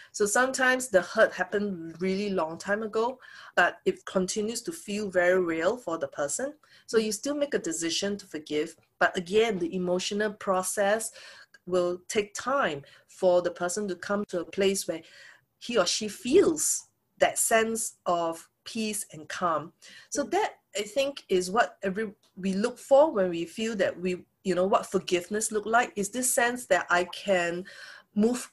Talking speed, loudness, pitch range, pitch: 170 wpm, -28 LUFS, 180-225 Hz, 200 Hz